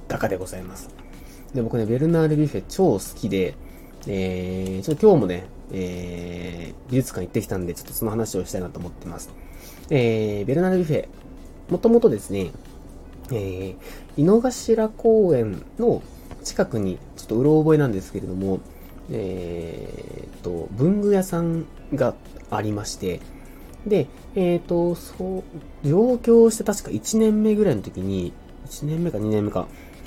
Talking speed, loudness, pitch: 295 characters per minute, -22 LUFS, 105 Hz